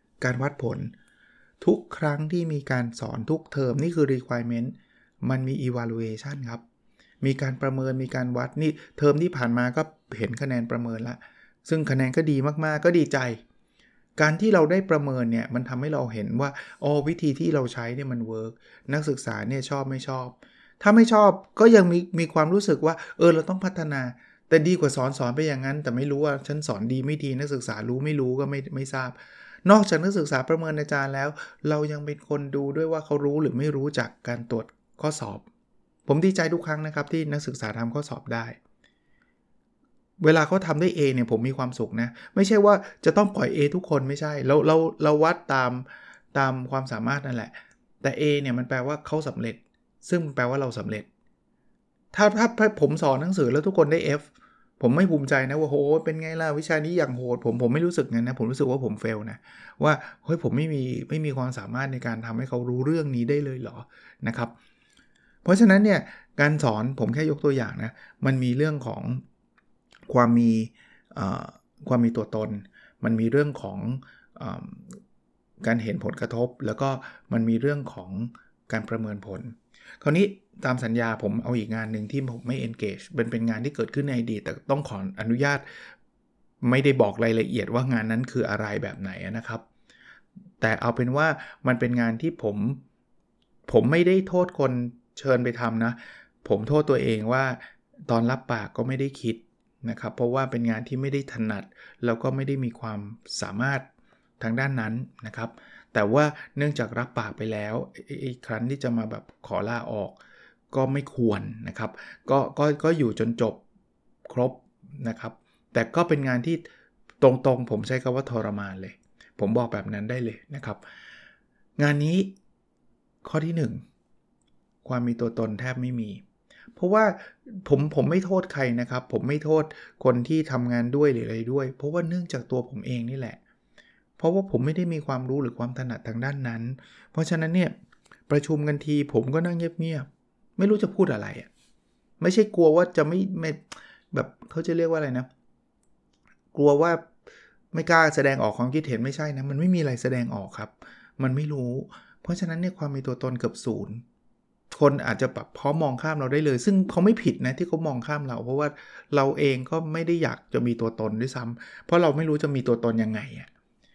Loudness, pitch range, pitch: -25 LUFS, 120-155 Hz, 135 Hz